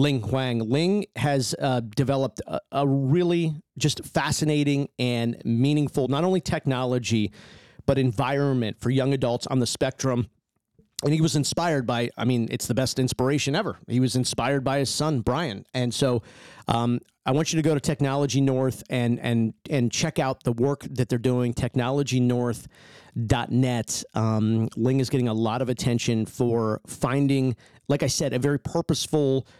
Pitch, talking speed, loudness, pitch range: 130 Hz, 165 wpm, -25 LUFS, 120-140 Hz